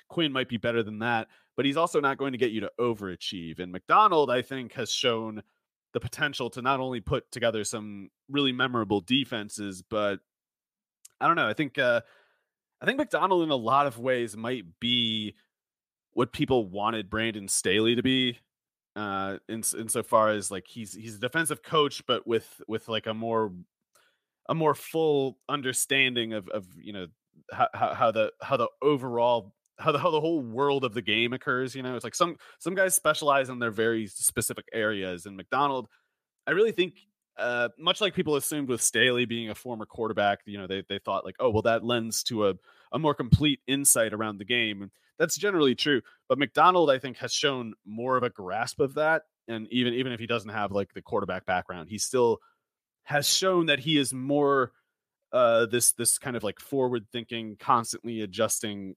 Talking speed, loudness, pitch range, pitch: 195 wpm, -27 LUFS, 110-140 Hz, 120 Hz